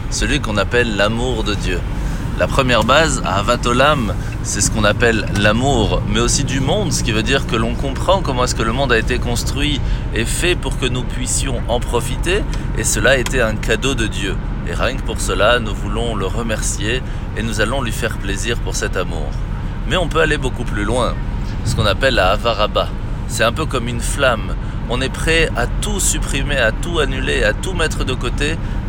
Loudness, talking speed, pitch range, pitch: -17 LUFS, 205 wpm, 105-120 Hz, 110 Hz